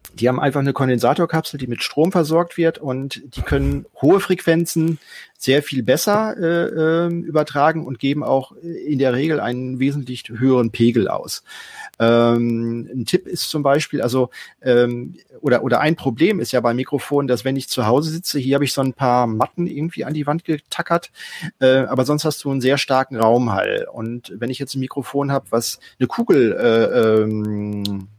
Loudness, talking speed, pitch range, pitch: -19 LUFS, 185 wpm, 120-155 Hz, 135 Hz